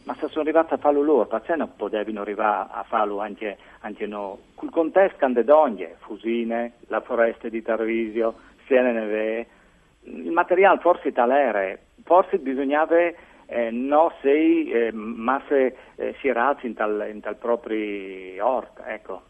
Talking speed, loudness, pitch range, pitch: 145 wpm, -23 LUFS, 110-155 Hz, 120 Hz